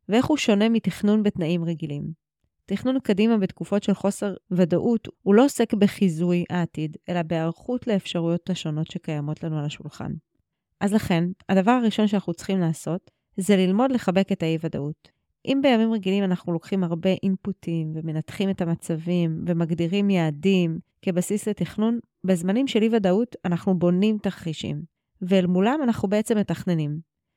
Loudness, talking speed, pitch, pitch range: -24 LUFS, 135 wpm, 190 Hz, 170-210 Hz